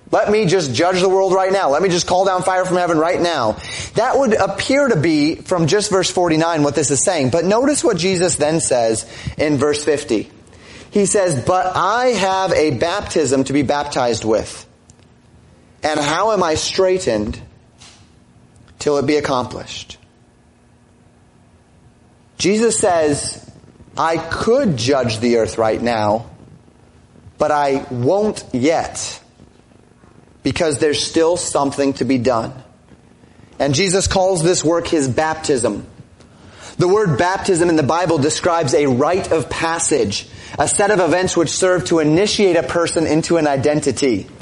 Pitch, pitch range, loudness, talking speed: 165 Hz, 140-185 Hz, -16 LUFS, 150 wpm